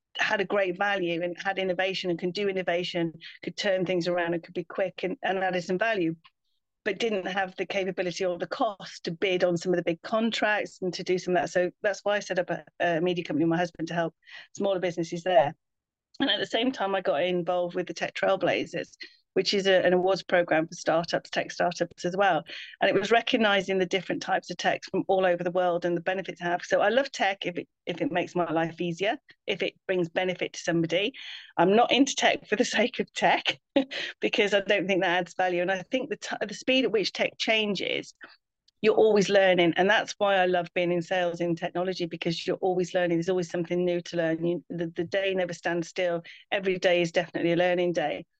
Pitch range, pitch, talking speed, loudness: 175-195 Hz, 180 Hz, 235 wpm, -27 LUFS